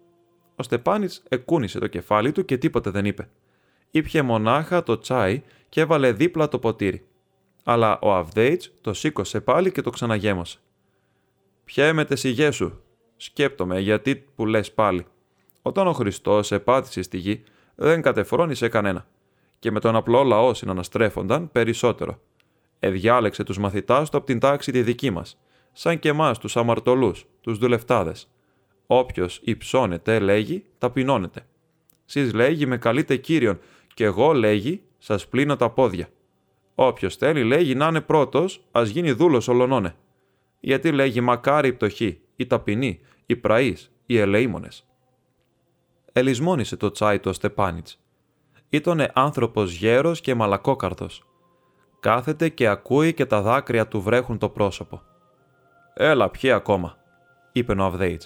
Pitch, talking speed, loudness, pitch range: 125 Hz, 140 wpm, -22 LUFS, 105-145 Hz